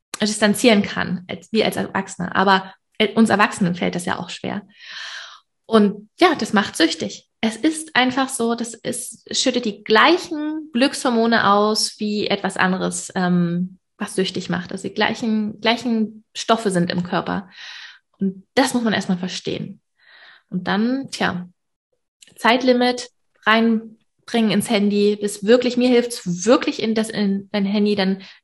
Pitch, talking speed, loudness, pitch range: 215 Hz, 145 wpm, -20 LUFS, 195-235 Hz